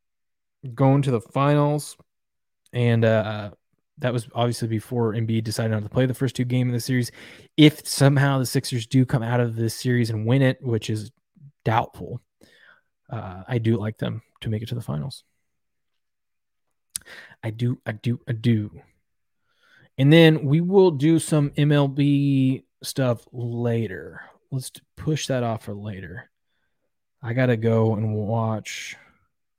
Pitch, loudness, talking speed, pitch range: 120 Hz, -22 LUFS, 155 wpm, 110-135 Hz